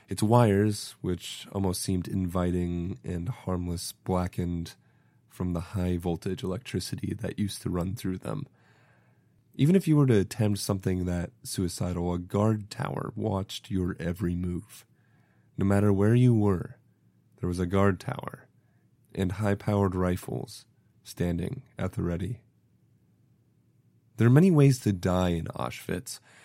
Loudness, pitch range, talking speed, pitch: -28 LUFS, 90-120 Hz, 140 wpm, 100 Hz